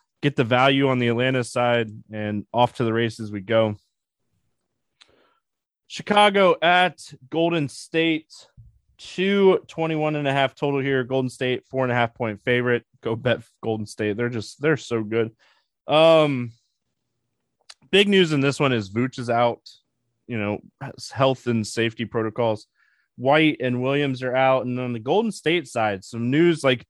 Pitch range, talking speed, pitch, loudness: 115-150 Hz, 165 wpm, 125 Hz, -22 LUFS